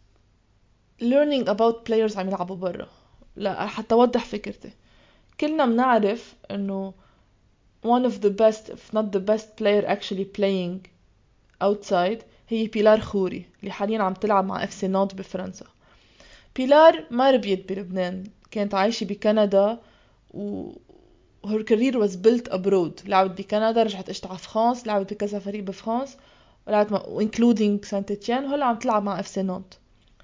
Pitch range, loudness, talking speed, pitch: 190-225 Hz, -23 LUFS, 145 wpm, 205 Hz